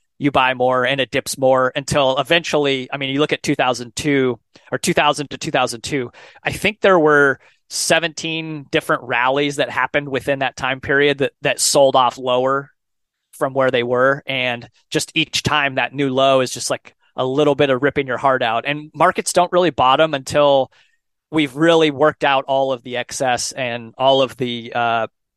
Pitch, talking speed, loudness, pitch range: 135 Hz, 200 wpm, -17 LUFS, 130-150 Hz